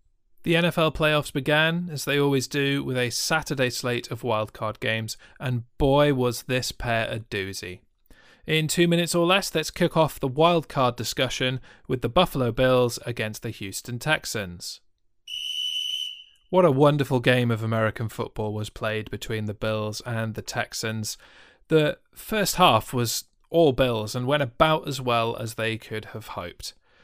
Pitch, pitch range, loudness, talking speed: 125 Hz, 110-150 Hz, -24 LUFS, 160 wpm